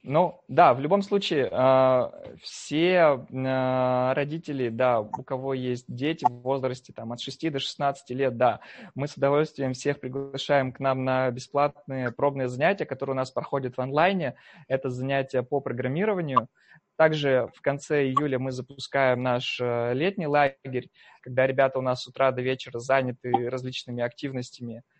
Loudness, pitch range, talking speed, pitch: -26 LUFS, 125-140 Hz, 150 wpm, 130 Hz